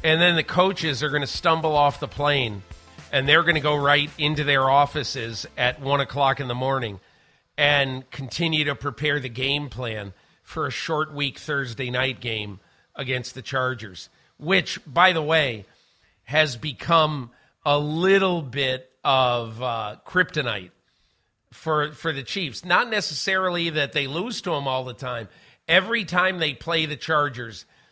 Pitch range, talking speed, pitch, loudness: 125-160 Hz, 160 wpm, 145 Hz, -23 LUFS